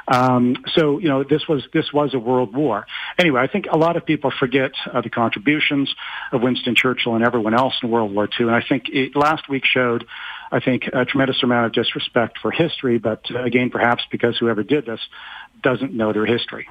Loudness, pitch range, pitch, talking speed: -19 LUFS, 115-145 Hz, 125 Hz, 215 wpm